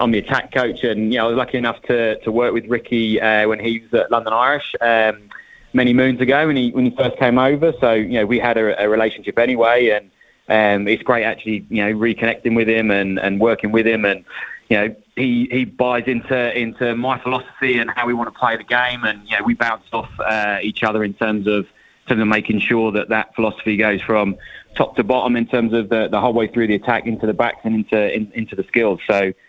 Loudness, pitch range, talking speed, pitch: -18 LUFS, 110-120 Hz, 250 wpm, 115 Hz